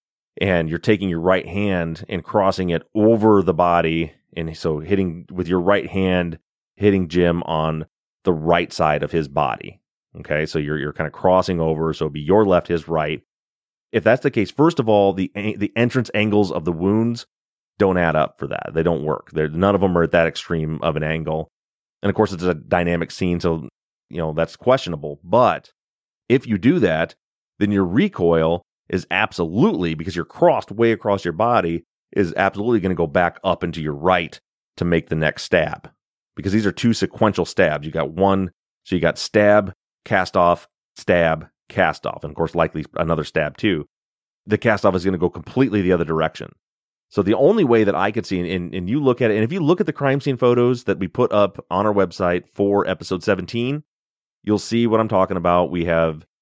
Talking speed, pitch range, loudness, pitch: 210 wpm, 80-105 Hz, -20 LUFS, 90 Hz